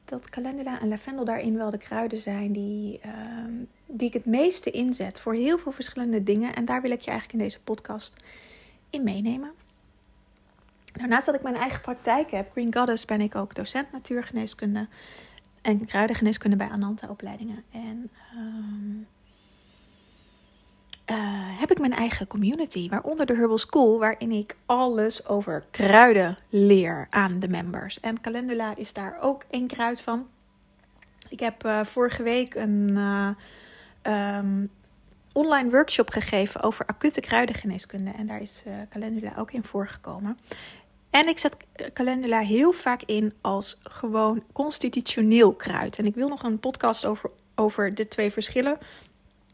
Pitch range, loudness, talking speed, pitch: 205-245 Hz, -25 LUFS, 150 wpm, 225 Hz